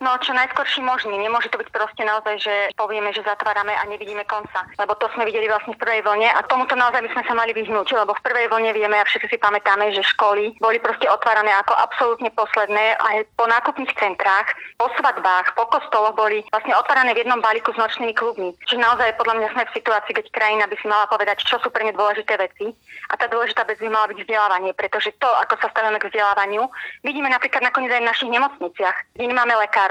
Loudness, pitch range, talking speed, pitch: -19 LUFS, 210-240 Hz, 220 wpm, 220 Hz